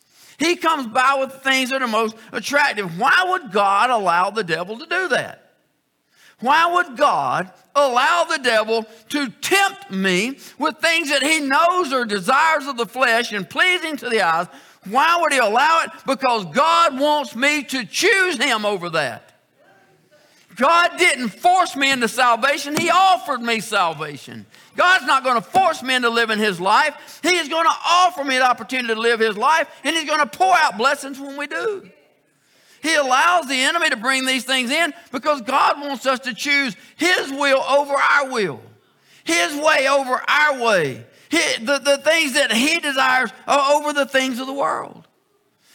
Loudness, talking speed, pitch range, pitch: -18 LUFS, 180 wpm, 245-320 Hz, 280 Hz